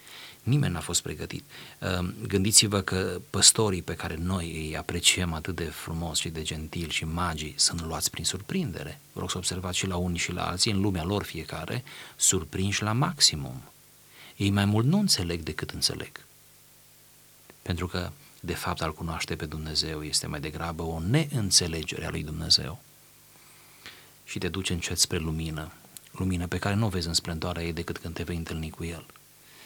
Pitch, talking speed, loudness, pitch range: 90 Hz, 175 wpm, -27 LUFS, 80-95 Hz